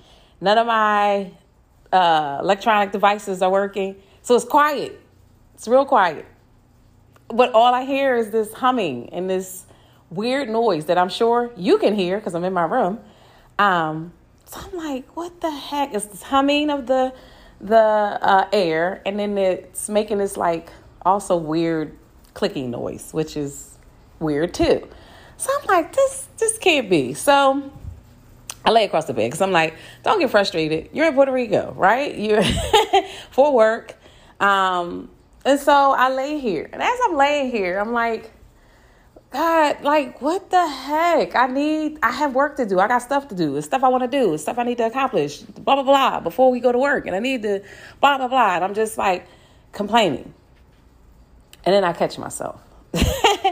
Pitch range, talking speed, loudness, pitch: 190-275 Hz, 180 wpm, -19 LUFS, 225 Hz